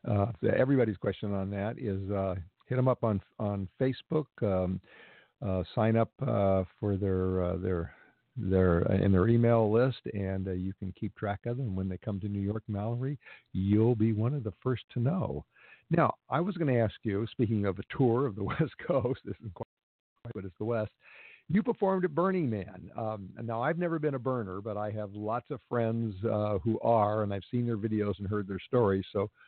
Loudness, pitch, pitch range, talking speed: -31 LUFS, 110 Hz, 100-120 Hz, 215 wpm